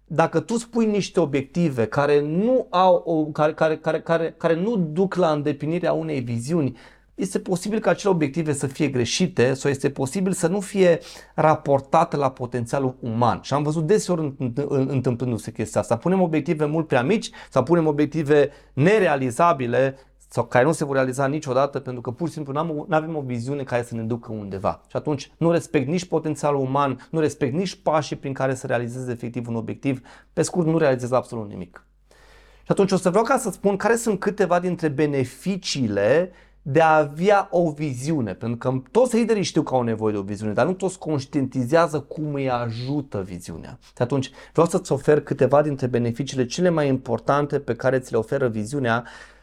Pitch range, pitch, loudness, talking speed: 130-170 Hz, 145 Hz, -22 LUFS, 185 wpm